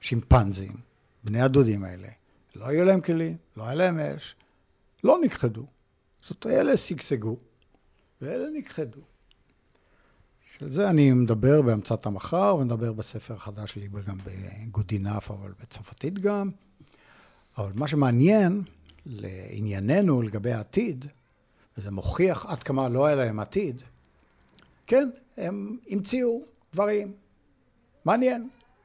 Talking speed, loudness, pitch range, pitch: 110 wpm, -26 LUFS, 105-180 Hz, 130 Hz